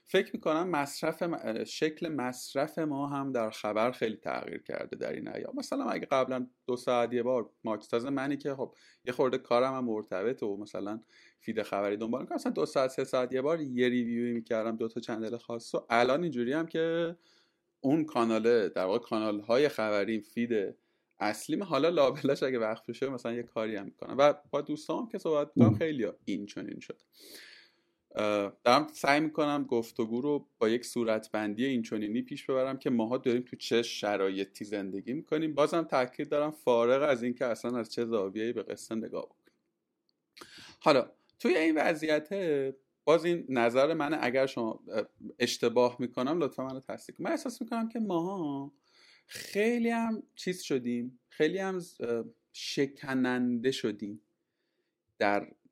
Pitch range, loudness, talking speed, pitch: 115-150 Hz, -31 LUFS, 160 wpm, 125 Hz